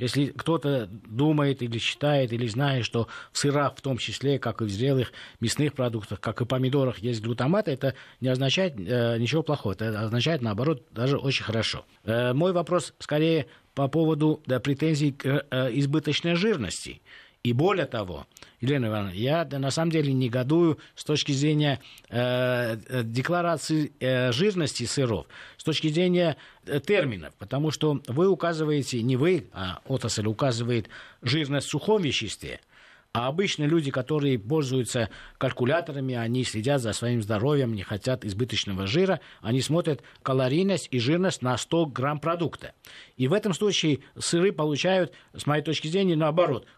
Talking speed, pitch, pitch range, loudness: 150 wpm, 135 Hz, 120-155 Hz, -26 LUFS